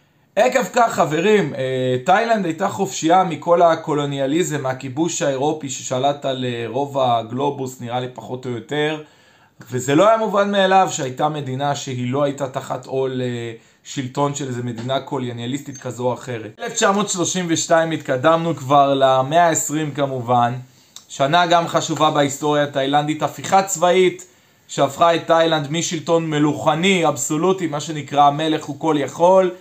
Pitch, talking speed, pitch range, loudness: 145 Hz, 130 wpm, 130-165 Hz, -19 LUFS